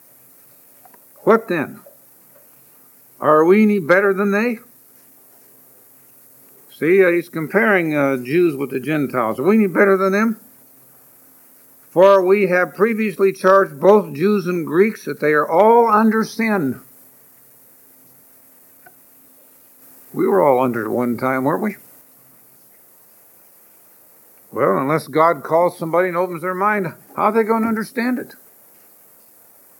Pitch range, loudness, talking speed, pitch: 155-210 Hz, -17 LUFS, 125 wpm, 190 Hz